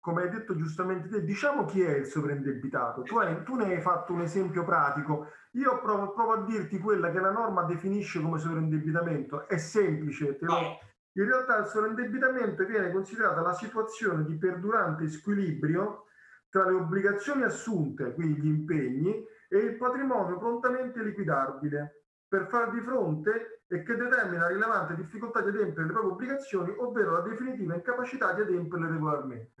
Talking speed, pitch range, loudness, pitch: 160 wpm, 165-220 Hz, -30 LUFS, 190 Hz